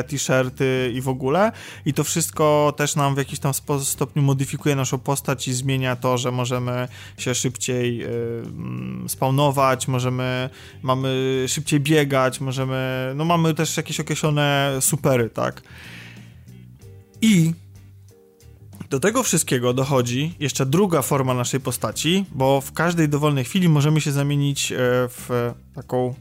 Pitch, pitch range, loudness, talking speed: 130 Hz, 125-145 Hz, -21 LUFS, 130 wpm